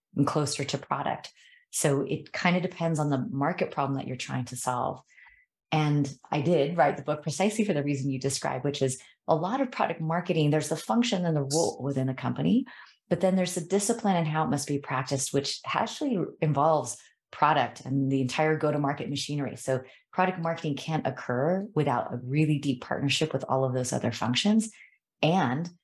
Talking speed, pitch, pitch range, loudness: 190 wpm, 150 Hz, 135-175 Hz, -28 LUFS